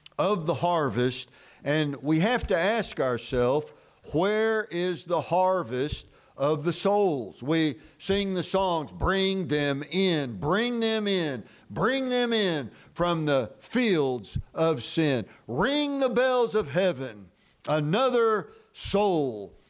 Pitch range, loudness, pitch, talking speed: 145-210 Hz, -27 LUFS, 175 Hz, 125 wpm